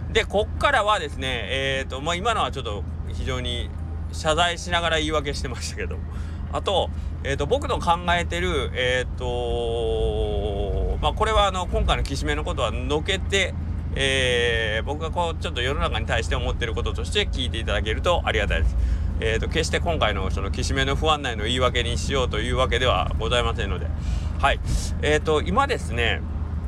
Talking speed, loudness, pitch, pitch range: 380 characters per minute, -24 LUFS, 80 Hz, 80-90 Hz